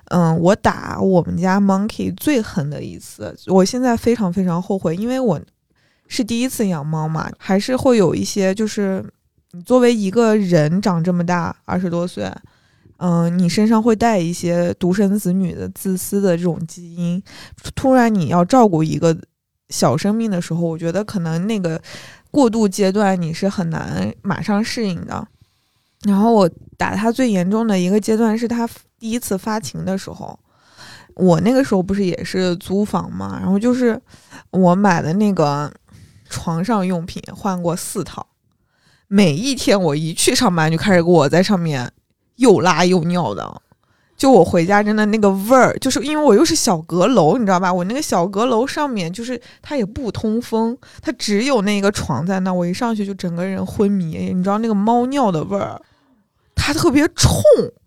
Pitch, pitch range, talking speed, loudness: 195 Hz, 175-225 Hz, 265 characters per minute, -17 LUFS